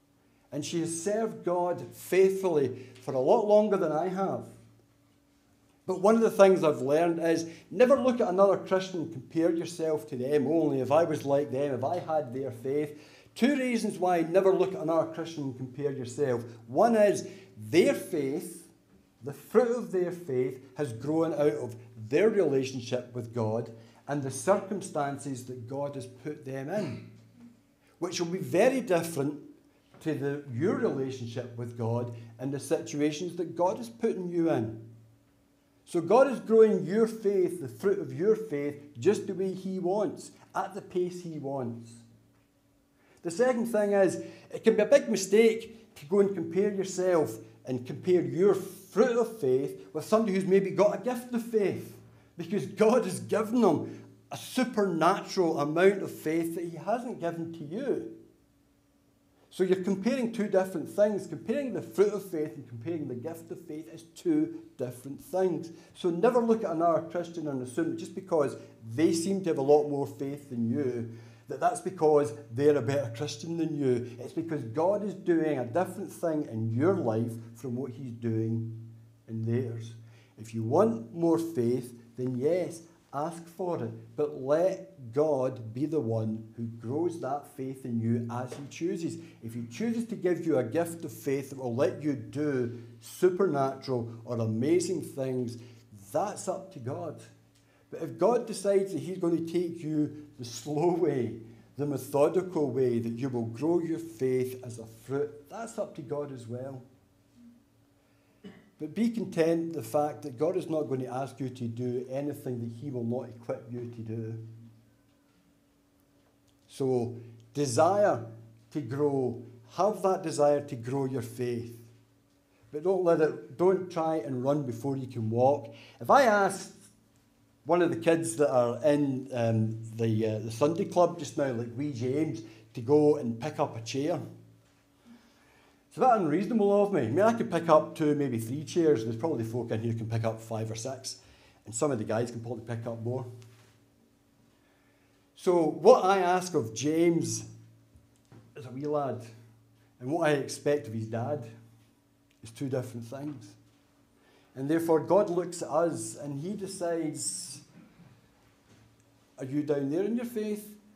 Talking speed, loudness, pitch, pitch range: 175 wpm, -29 LUFS, 145 Hz, 120-180 Hz